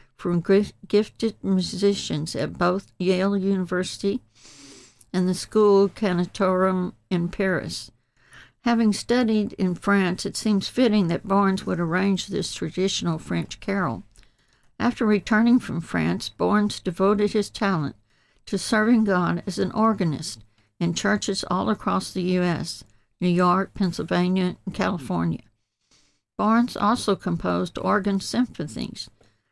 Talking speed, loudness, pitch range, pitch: 120 wpm, -23 LUFS, 170-205 Hz, 190 Hz